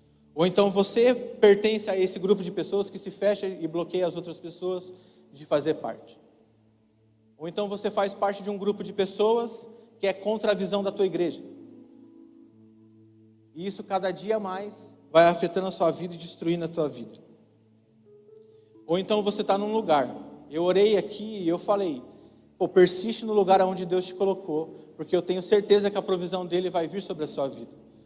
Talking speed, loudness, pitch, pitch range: 185 wpm, -26 LUFS, 190 Hz, 165-205 Hz